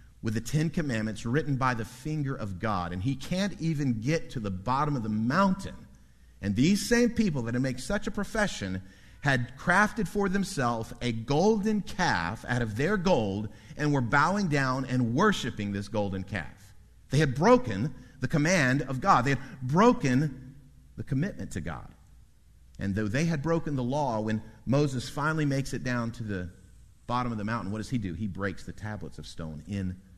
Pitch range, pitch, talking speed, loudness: 105-155 Hz, 125 Hz, 190 wpm, -28 LUFS